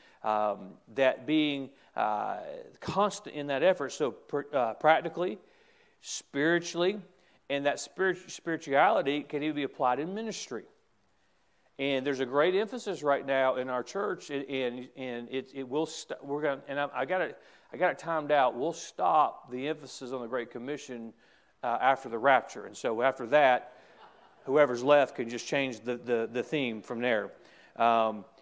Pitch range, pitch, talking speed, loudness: 130-160 Hz, 140 Hz, 165 wpm, -30 LUFS